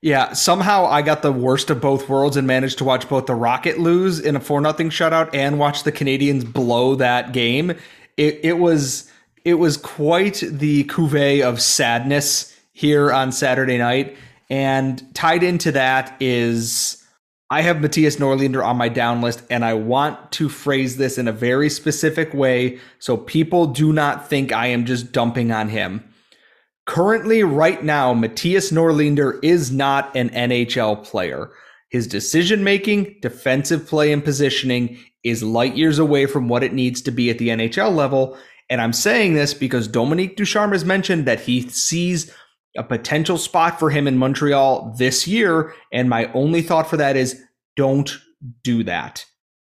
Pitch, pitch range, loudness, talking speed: 140 Hz, 125-160 Hz, -18 LUFS, 170 wpm